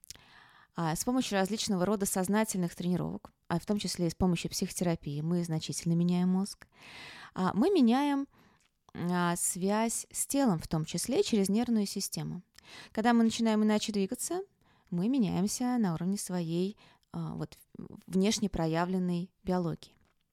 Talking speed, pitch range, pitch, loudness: 125 wpm, 175-215 Hz, 190 Hz, -31 LUFS